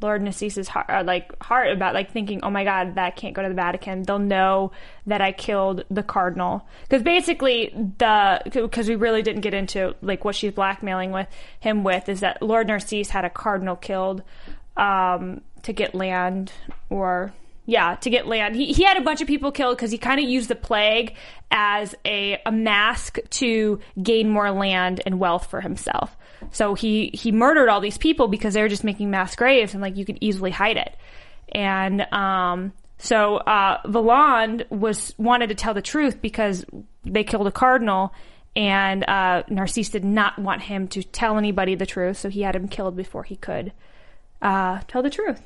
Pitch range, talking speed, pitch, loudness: 190-225 Hz, 195 wpm, 205 Hz, -22 LUFS